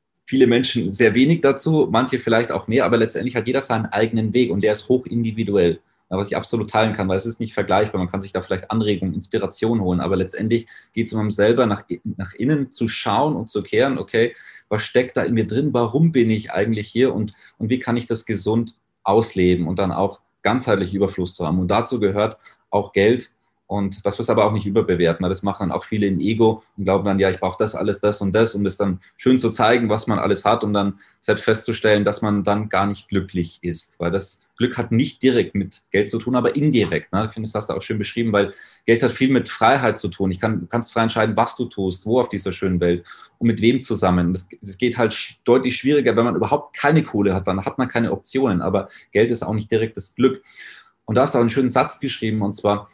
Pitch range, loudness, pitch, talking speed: 100-120 Hz, -20 LUFS, 110 Hz, 245 wpm